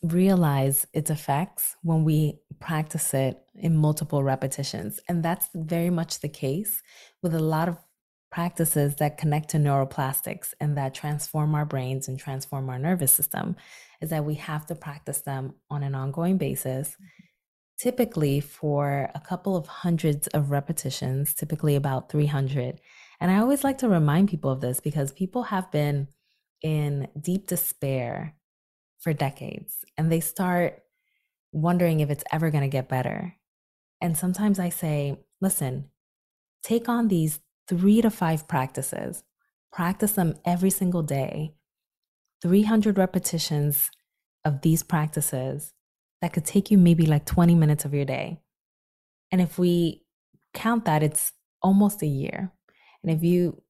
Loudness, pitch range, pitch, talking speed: -25 LUFS, 145-180 Hz, 155 Hz, 145 wpm